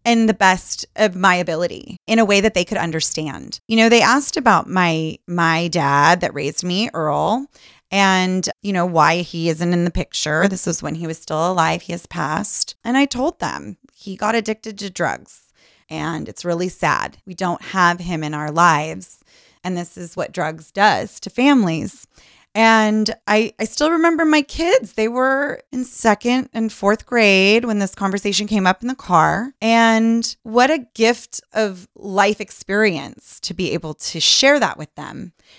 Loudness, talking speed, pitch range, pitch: -18 LUFS, 185 wpm, 175-225 Hz, 200 Hz